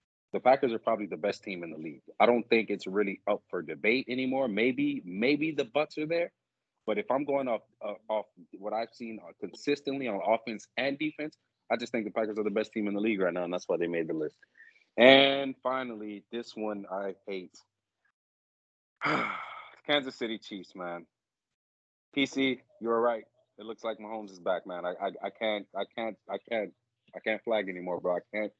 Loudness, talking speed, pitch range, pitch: -31 LUFS, 200 wpm, 100-135 Hz, 110 Hz